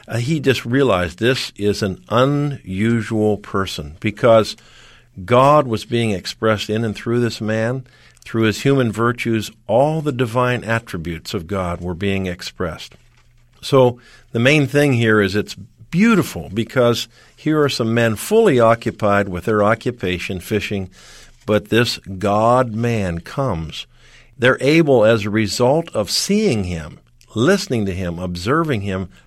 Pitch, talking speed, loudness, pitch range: 115 Hz, 140 wpm, -18 LUFS, 100-125 Hz